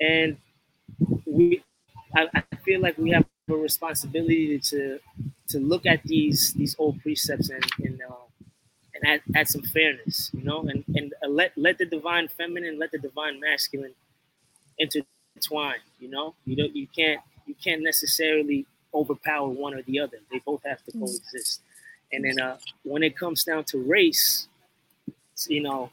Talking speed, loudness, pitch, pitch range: 160 wpm, -25 LUFS, 150 Hz, 140-160 Hz